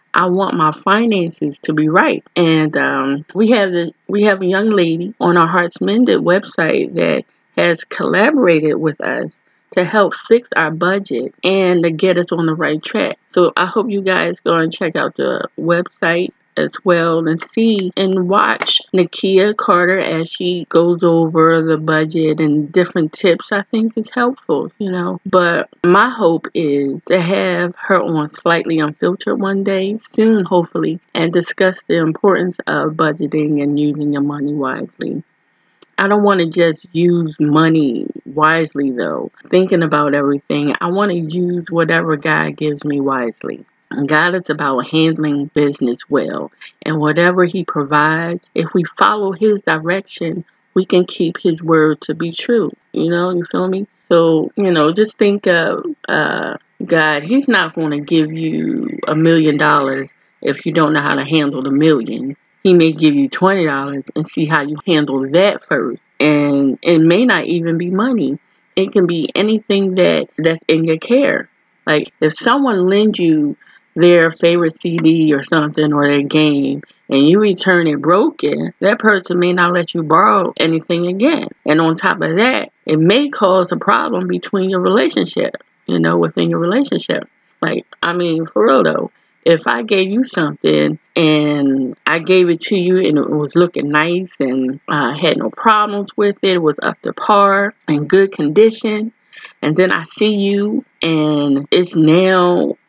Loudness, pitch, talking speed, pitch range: -15 LUFS, 170 Hz, 170 wpm, 155-190 Hz